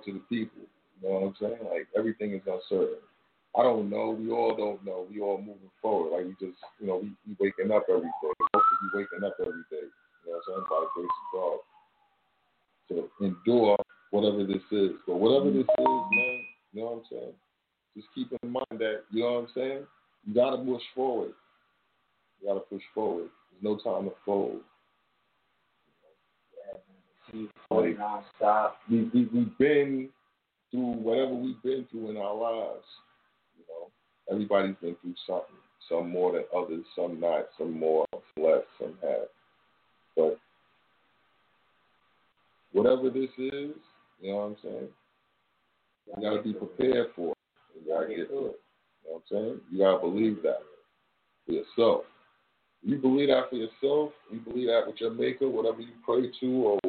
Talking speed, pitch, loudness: 175 wpm, 120 Hz, -29 LUFS